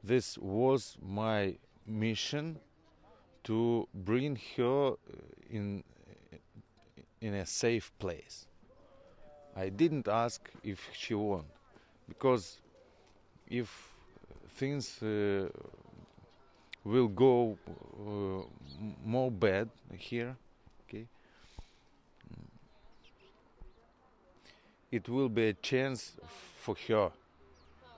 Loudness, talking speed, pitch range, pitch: -34 LUFS, 75 wpm, 100-125 Hz, 115 Hz